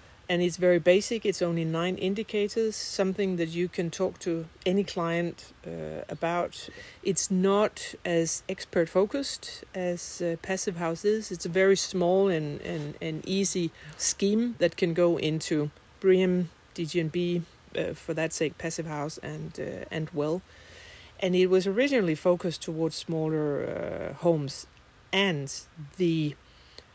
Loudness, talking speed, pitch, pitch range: -28 LUFS, 140 wpm, 175 Hz, 160-190 Hz